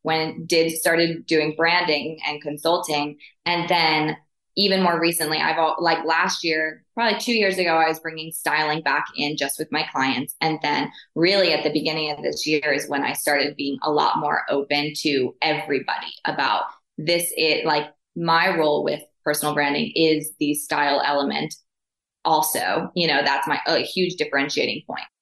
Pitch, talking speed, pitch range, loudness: 155 Hz, 175 wpm, 150-165 Hz, -21 LUFS